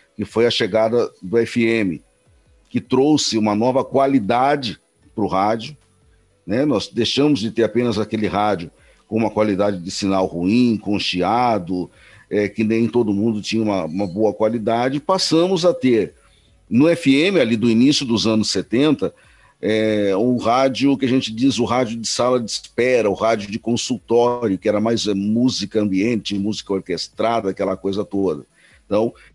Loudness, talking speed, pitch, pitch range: -19 LUFS, 160 wpm, 110 Hz, 105-120 Hz